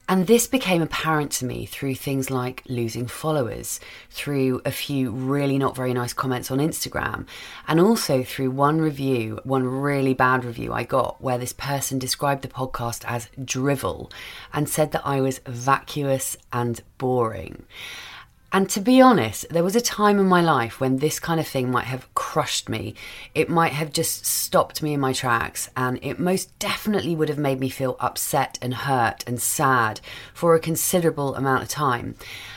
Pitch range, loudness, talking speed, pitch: 125-155 Hz, -23 LUFS, 180 wpm, 135 Hz